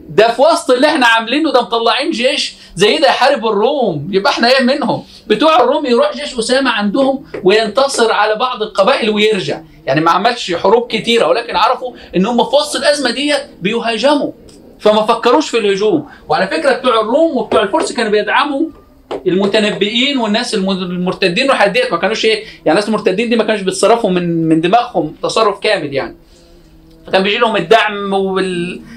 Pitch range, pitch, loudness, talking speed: 200-260 Hz, 230 Hz, -13 LUFS, 165 wpm